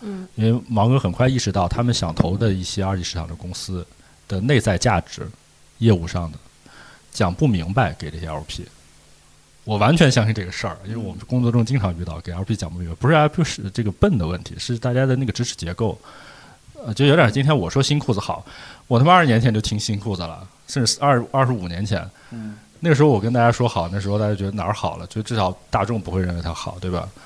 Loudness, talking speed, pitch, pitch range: -20 LUFS, 350 characters per minute, 105 Hz, 90-125 Hz